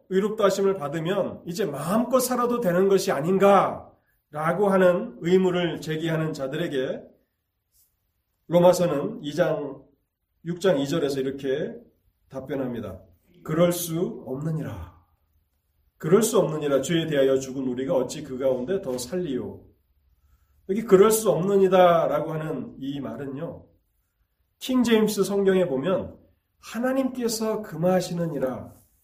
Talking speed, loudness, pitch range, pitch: 260 characters per minute, -24 LUFS, 120-185 Hz, 155 Hz